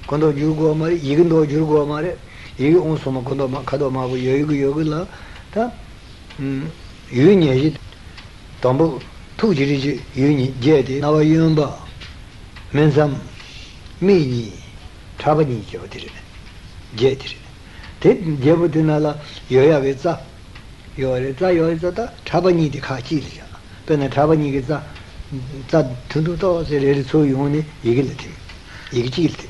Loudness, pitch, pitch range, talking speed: -18 LUFS, 140 Hz, 125-155 Hz, 110 wpm